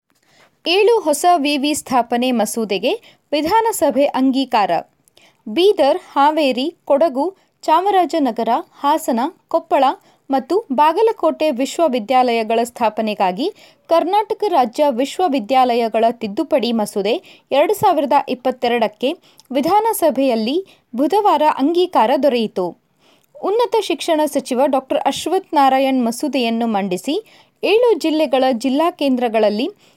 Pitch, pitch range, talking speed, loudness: 285 Hz, 250-335 Hz, 80 wpm, -17 LUFS